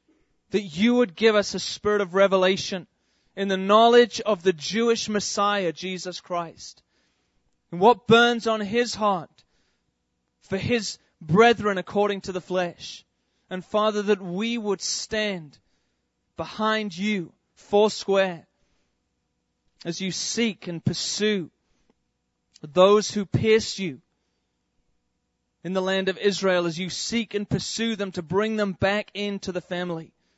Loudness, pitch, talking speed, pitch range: -23 LUFS, 190 Hz, 130 wpm, 155-210 Hz